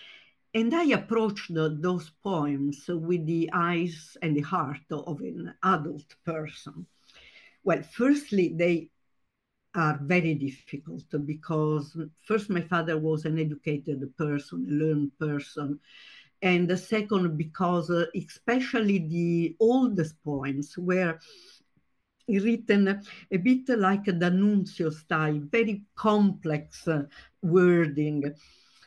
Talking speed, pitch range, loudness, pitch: 105 wpm, 155-195 Hz, -27 LUFS, 170 Hz